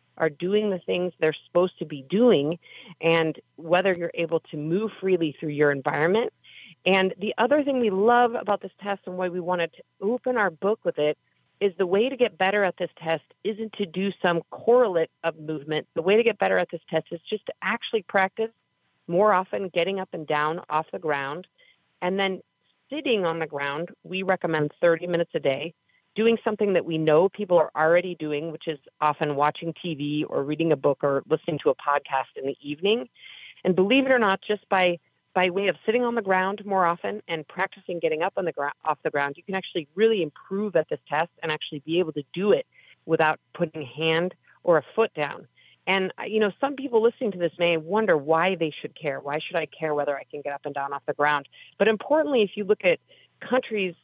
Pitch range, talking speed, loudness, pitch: 155-205 Hz, 220 wpm, -25 LUFS, 175 Hz